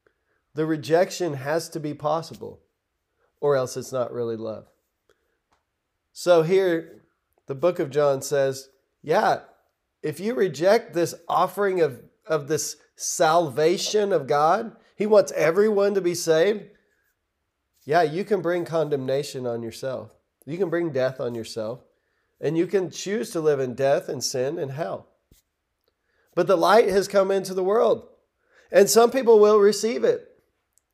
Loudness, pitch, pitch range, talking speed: -23 LUFS, 175 Hz, 145-205 Hz, 145 wpm